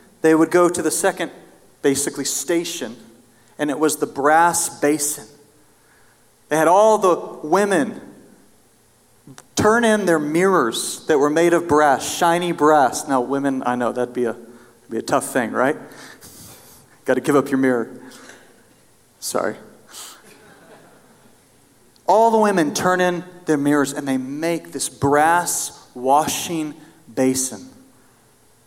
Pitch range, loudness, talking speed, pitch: 135-170 Hz, -19 LUFS, 130 wpm, 150 Hz